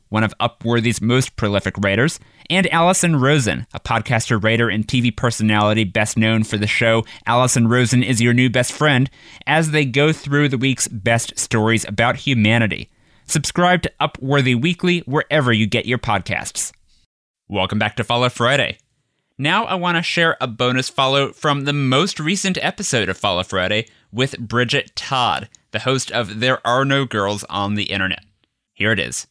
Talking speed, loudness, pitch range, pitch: 170 wpm, -18 LUFS, 110-140 Hz, 120 Hz